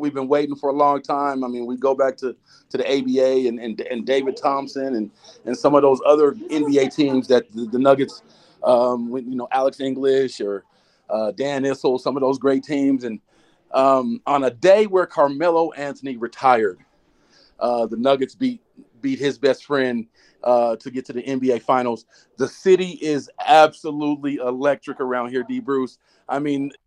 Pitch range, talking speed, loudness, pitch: 125-145 Hz, 185 wpm, -20 LUFS, 135 Hz